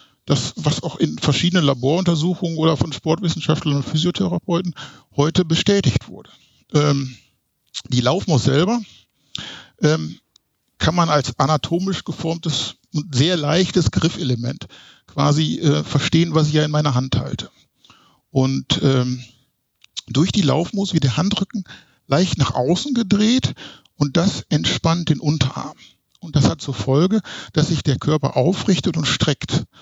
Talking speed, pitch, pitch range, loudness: 135 wpm, 155 Hz, 135-175 Hz, -19 LUFS